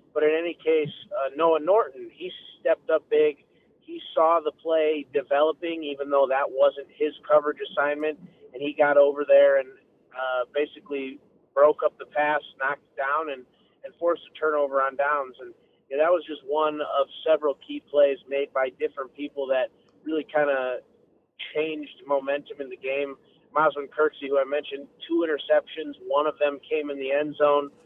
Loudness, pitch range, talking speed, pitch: -25 LUFS, 140-160 Hz, 180 wpm, 150 Hz